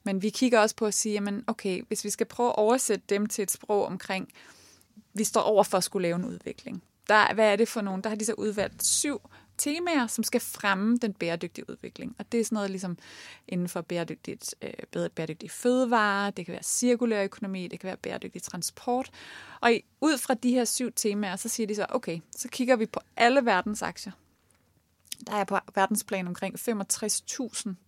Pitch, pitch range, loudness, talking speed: 210 Hz, 195-235 Hz, -28 LUFS, 200 wpm